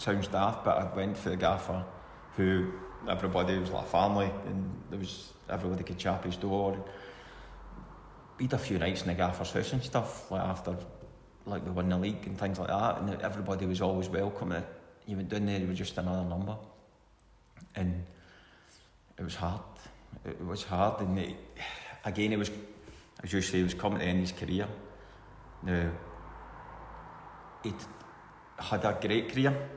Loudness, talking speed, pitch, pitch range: -33 LUFS, 170 wpm, 95 Hz, 90-105 Hz